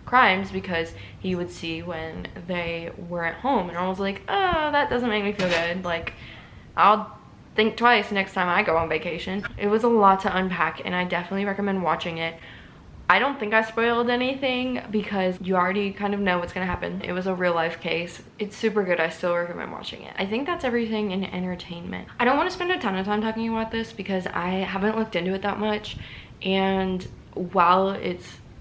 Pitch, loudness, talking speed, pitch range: 190 Hz, -24 LUFS, 210 wpm, 175-220 Hz